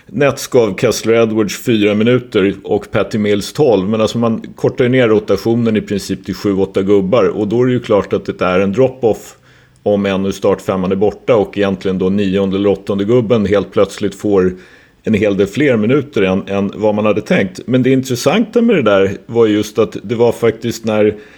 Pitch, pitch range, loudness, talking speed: 105 Hz, 100-115 Hz, -14 LUFS, 205 wpm